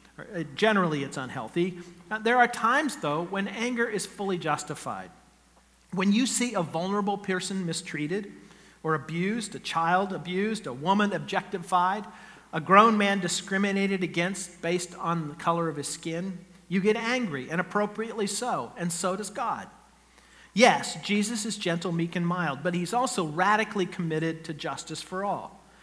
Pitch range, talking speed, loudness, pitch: 170-205 Hz, 155 wpm, -27 LUFS, 185 Hz